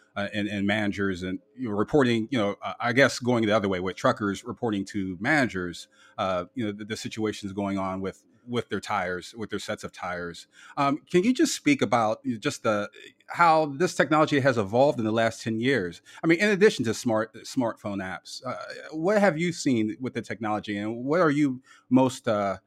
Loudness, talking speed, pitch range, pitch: -26 LUFS, 210 wpm, 100-140 Hz, 115 Hz